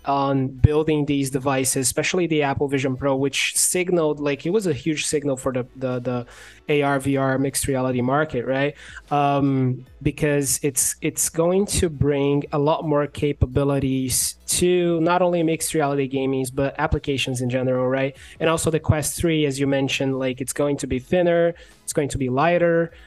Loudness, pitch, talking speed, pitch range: -21 LUFS, 140 Hz, 175 wpm, 130-155 Hz